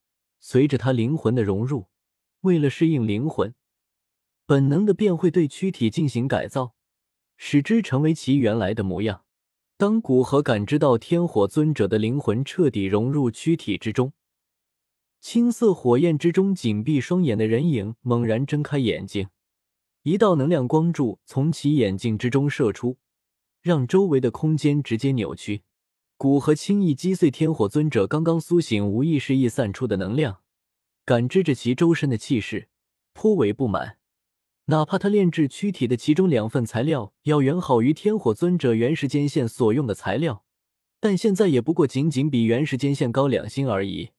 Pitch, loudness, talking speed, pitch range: 135 Hz, -22 LUFS, 250 characters per minute, 115-160 Hz